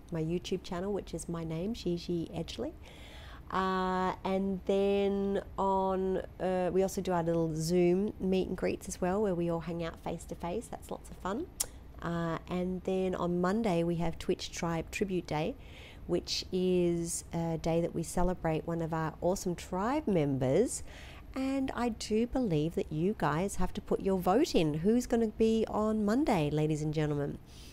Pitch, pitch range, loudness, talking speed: 180 Hz, 165-195 Hz, -33 LUFS, 180 wpm